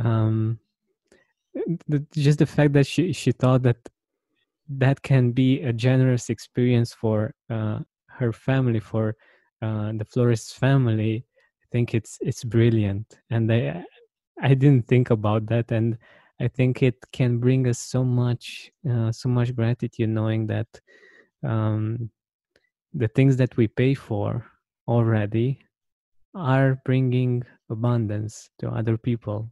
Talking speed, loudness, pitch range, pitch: 135 wpm, -23 LUFS, 110-130 Hz, 120 Hz